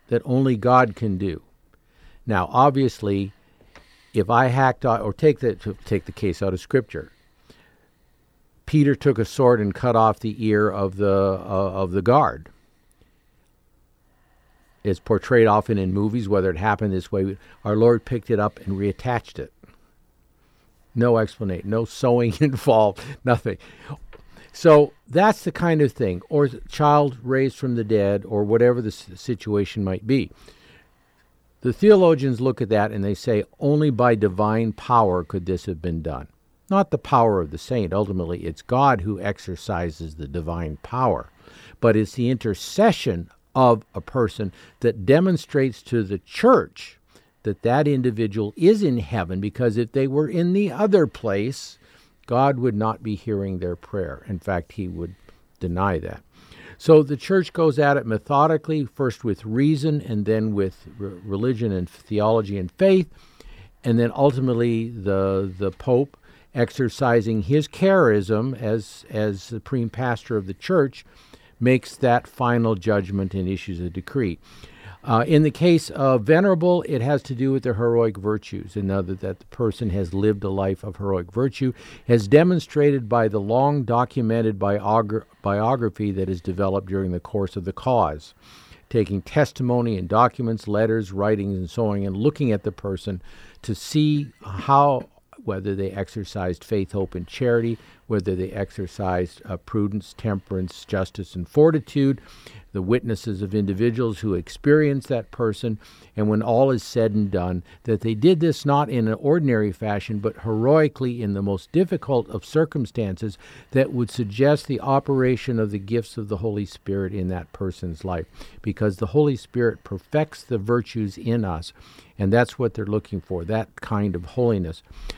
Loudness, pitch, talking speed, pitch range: -22 LUFS, 110 Hz, 160 wpm, 100-130 Hz